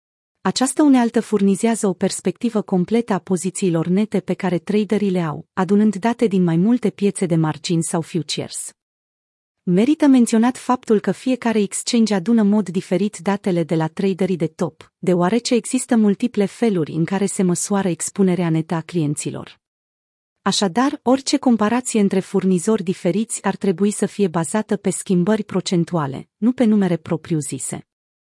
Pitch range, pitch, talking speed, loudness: 175-215 Hz, 195 Hz, 150 wpm, -19 LUFS